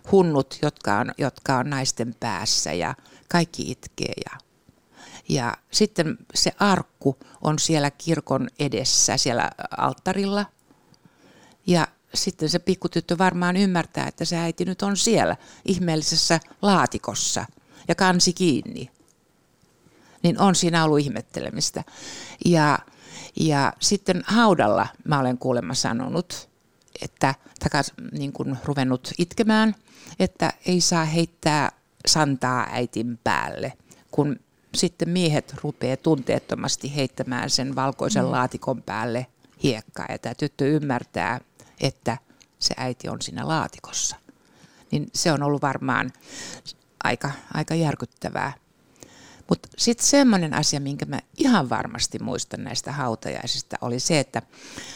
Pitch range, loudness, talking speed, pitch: 130-180 Hz, -23 LUFS, 115 wpm, 150 Hz